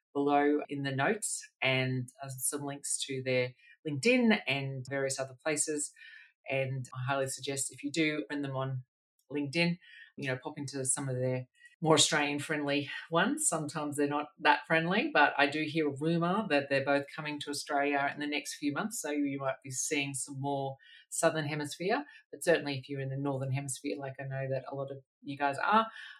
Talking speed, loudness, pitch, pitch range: 195 wpm, -32 LUFS, 145 Hz, 135-155 Hz